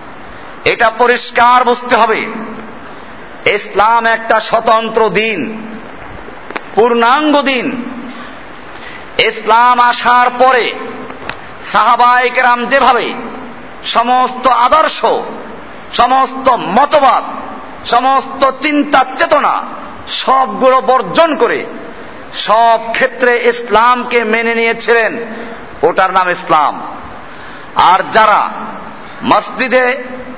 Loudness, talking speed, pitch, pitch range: -11 LUFS, 70 wpm, 245 Hz, 230-260 Hz